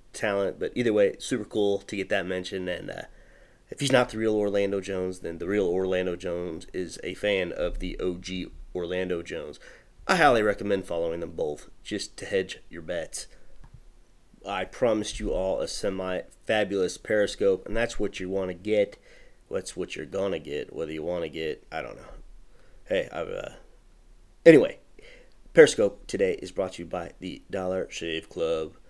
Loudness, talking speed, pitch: -27 LUFS, 180 wpm, 105 Hz